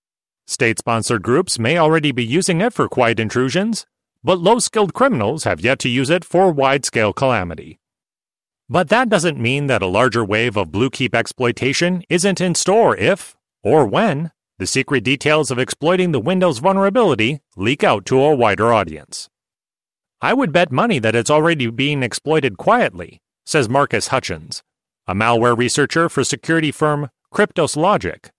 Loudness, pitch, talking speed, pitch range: -17 LUFS, 140 Hz, 150 wpm, 120-175 Hz